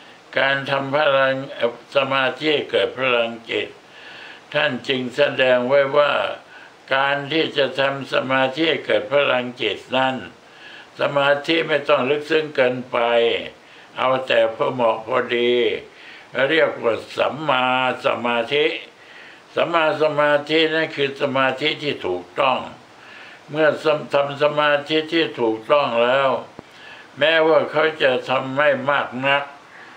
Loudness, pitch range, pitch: -19 LUFS, 130-150 Hz, 140 Hz